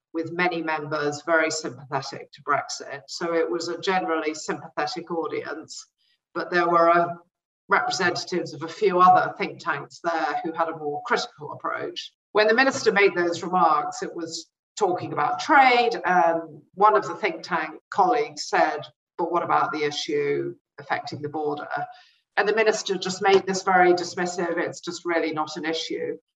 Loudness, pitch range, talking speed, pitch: -24 LUFS, 165-215 Hz, 165 wpm, 175 Hz